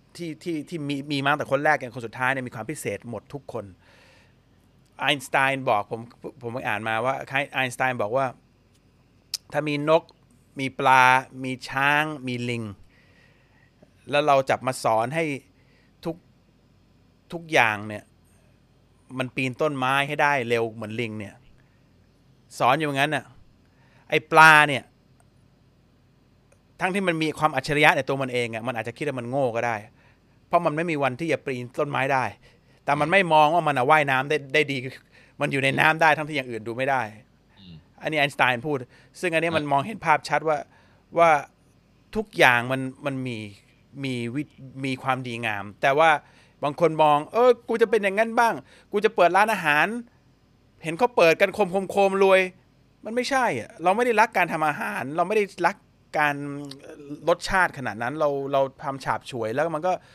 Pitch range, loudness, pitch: 125-155 Hz, -23 LUFS, 135 Hz